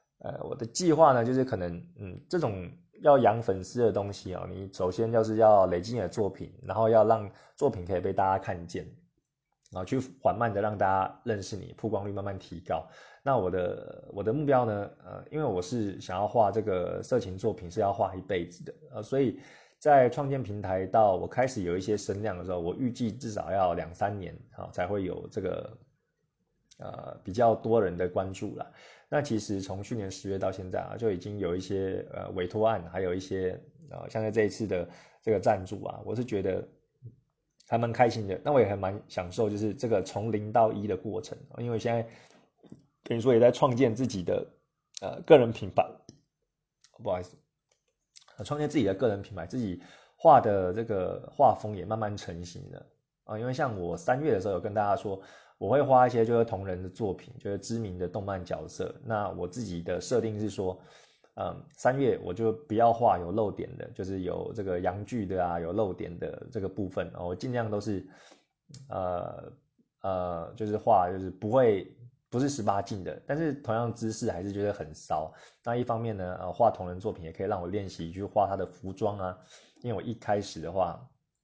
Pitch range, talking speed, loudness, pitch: 95-120 Hz, 290 characters per minute, -29 LUFS, 105 Hz